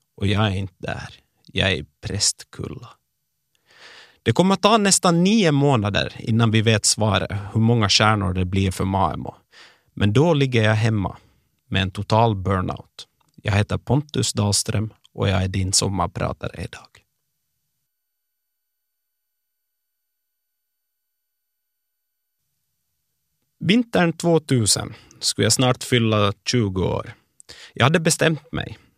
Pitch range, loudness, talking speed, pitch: 100-135 Hz, -20 LUFS, 120 wpm, 110 Hz